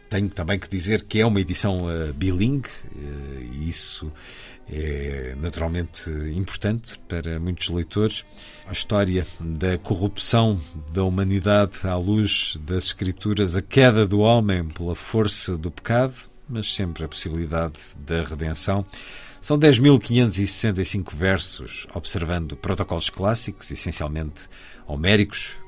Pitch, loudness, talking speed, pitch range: 95 Hz, -21 LUFS, 115 wpm, 80-105 Hz